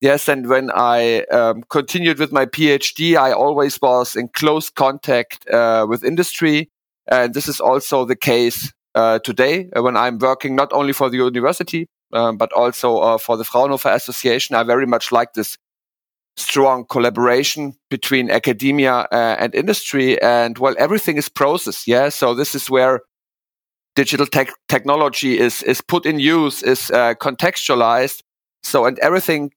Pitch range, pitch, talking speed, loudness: 120-145 Hz, 135 Hz, 160 wpm, -16 LUFS